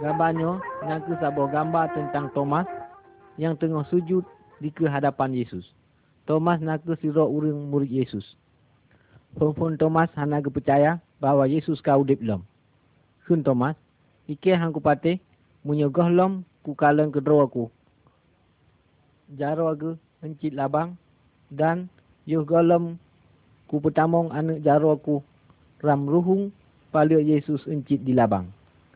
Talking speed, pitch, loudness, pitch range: 120 wpm, 150 Hz, -24 LUFS, 140-165 Hz